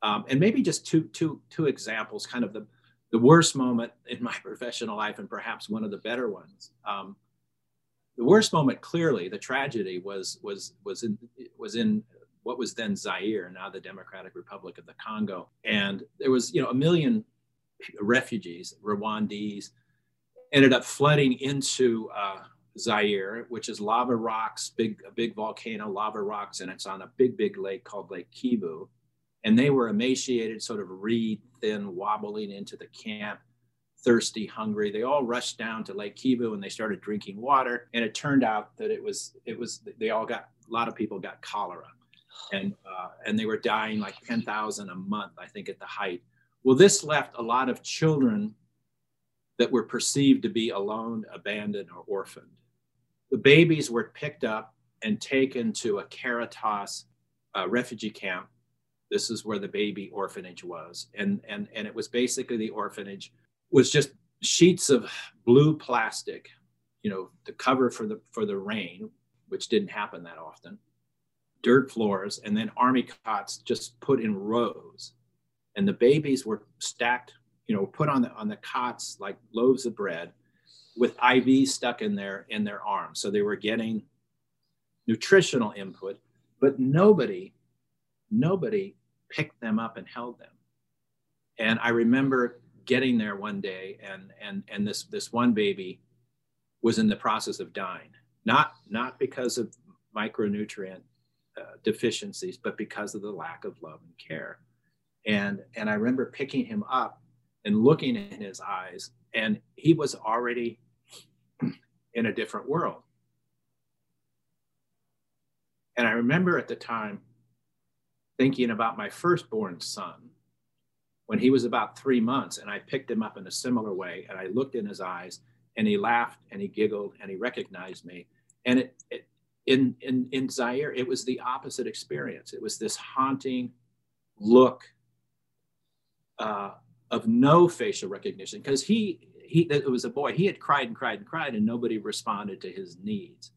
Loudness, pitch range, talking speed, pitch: -27 LUFS, 105-175 Hz, 165 wpm, 120 Hz